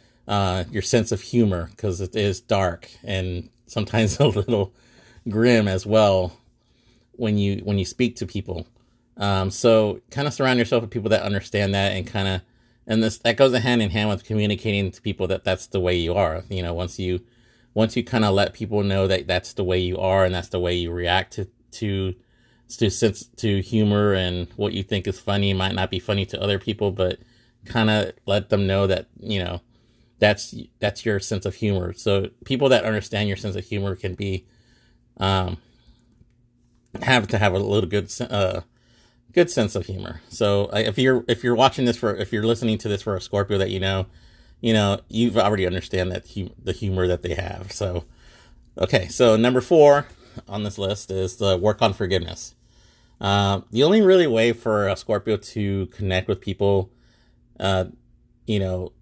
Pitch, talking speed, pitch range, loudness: 100 Hz, 195 wpm, 95-115 Hz, -22 LUFS